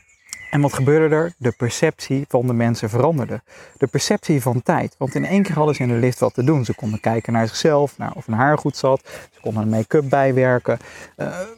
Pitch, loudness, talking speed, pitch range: 135 Hz, -19 LUFS, 225 wpm, 120-150 Hz